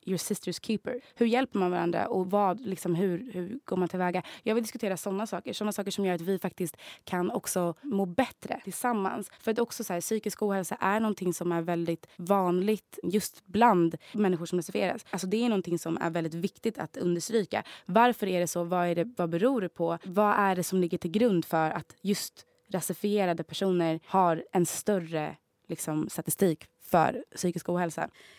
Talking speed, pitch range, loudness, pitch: 190 wpm, 175-210 Hz, -30 LUFS, 185 Hz